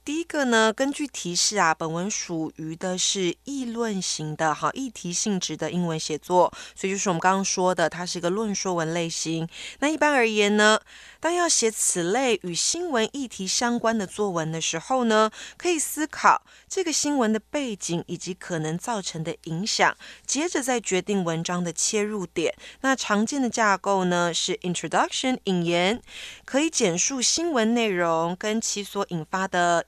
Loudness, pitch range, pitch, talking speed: -24 LUFS, 175-240 Hz, 195 Hz, 280 characters per minute